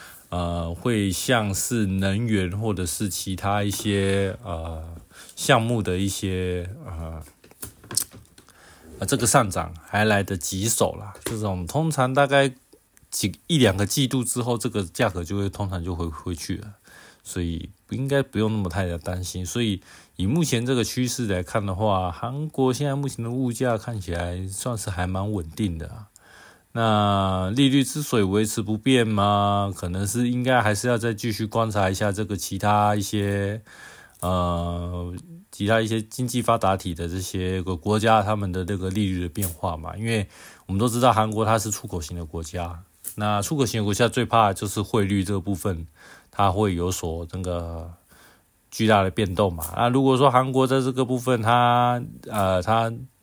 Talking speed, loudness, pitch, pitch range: 255 characters per minute, -24 LUFS, 105 Hz, 90-120 Hz